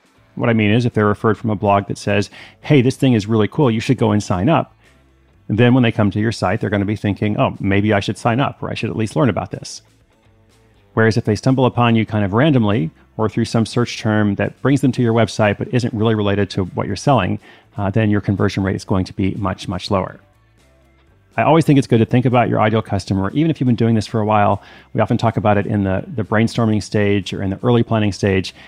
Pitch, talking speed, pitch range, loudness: 110 Hz, 265 wpm, 100-120 Hz, -17 LUFS